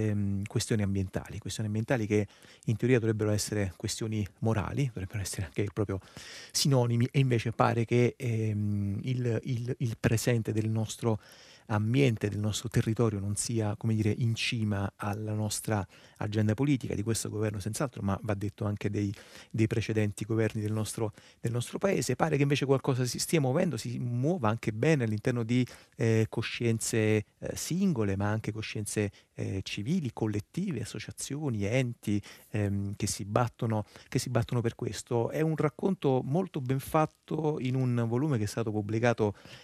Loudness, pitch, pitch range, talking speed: -31 LUFS, 115 Hz, 105-125 Hz, 160 wpm